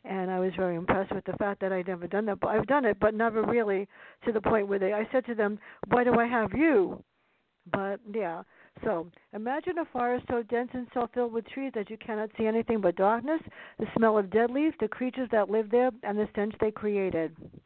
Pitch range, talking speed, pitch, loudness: 200-245 Hz, 235 wpm, 220 Hz, -29 LUFS